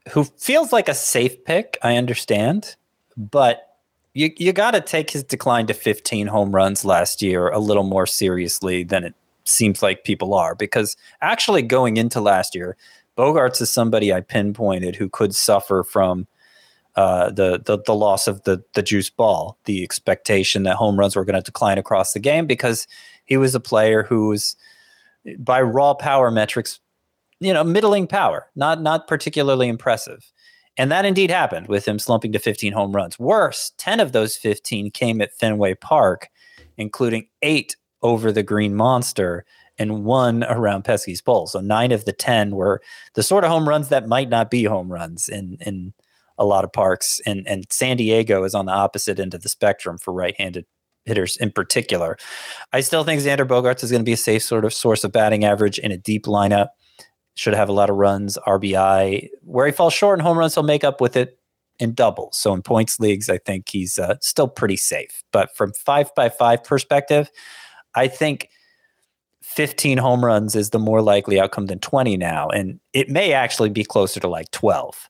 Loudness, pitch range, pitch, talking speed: -19 LUFS, 100-140 Hz, 110 Hz, 190 wpm